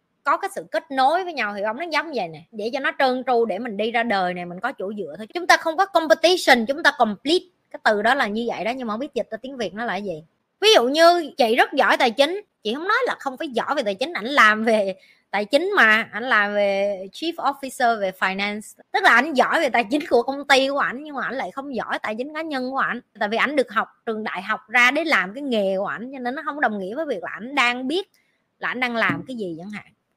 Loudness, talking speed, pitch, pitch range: -21 LUFS, 290 wpm, 245 Hz, 215-285 Hz